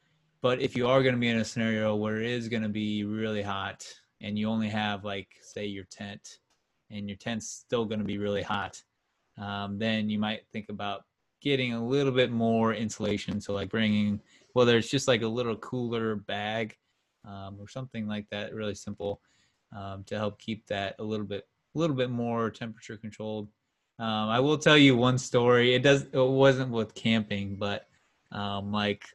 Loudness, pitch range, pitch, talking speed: -28 LUFS, 105-120 Hz, 110 Hz, 195 wpm